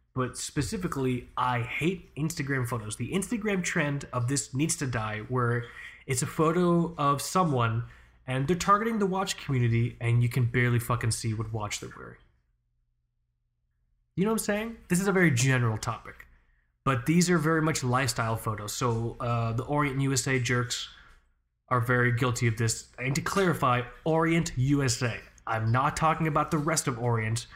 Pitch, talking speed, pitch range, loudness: 125 Hz, 170 wpm, 115-160 Hz, -28 LUFS